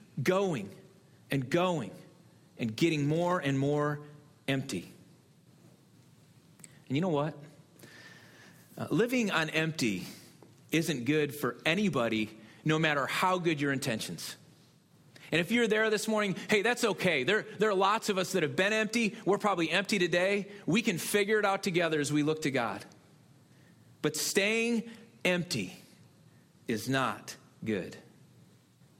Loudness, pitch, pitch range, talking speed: -30 LUFS, 165 Hz, 145-200 Hz, 140 wpm